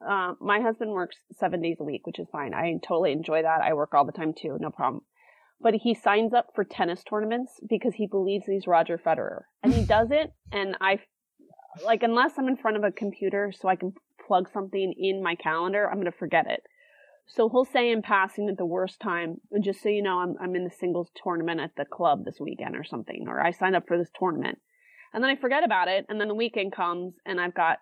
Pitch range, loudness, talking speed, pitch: 175-225 Hz, -27 LUFS, 240 wpm, 195 Hz